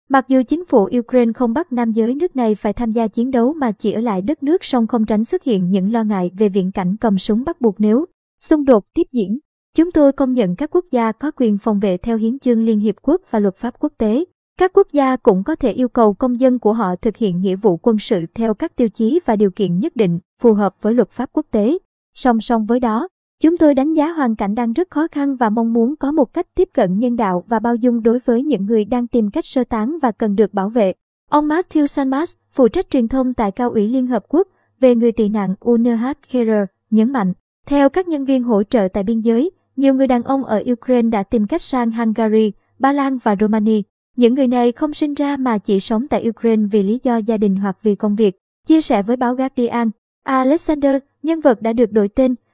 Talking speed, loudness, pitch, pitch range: 245 wpm, -17 LUFS, 240 Hz, 220-275 Hz